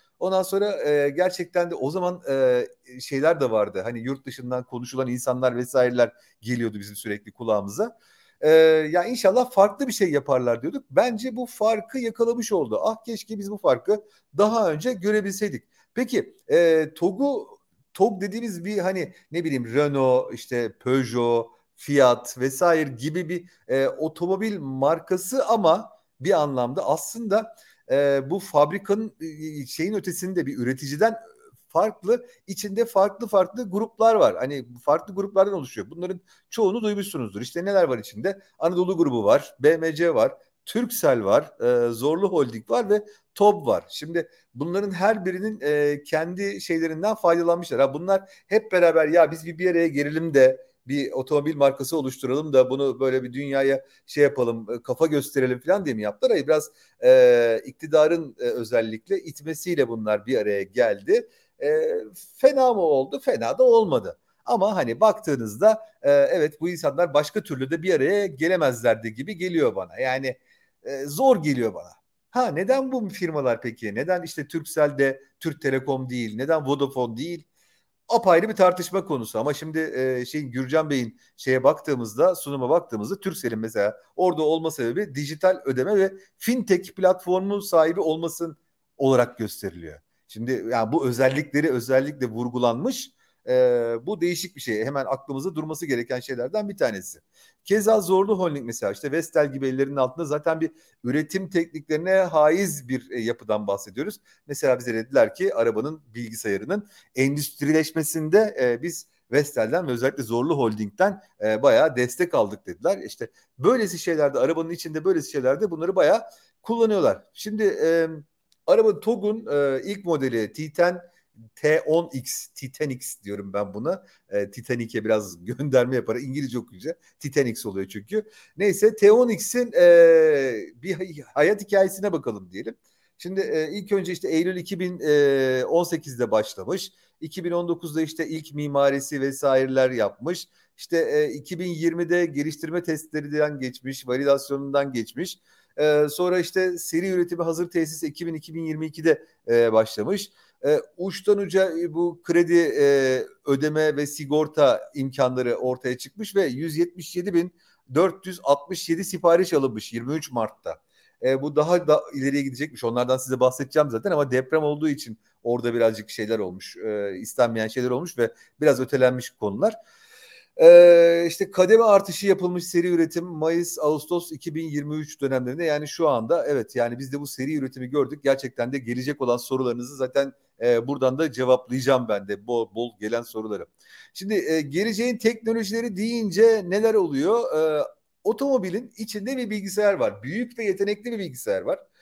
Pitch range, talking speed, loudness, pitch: 130-200 Hz, 140 wpm, -23 LUFS, 160 Hz